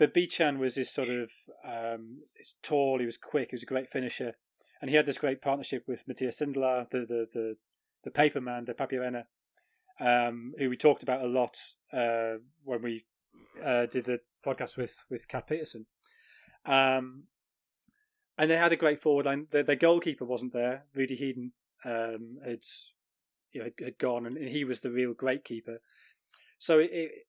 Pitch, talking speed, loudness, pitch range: 130 Hz, 180 wpm, -31 LUFS, 120-145 Hz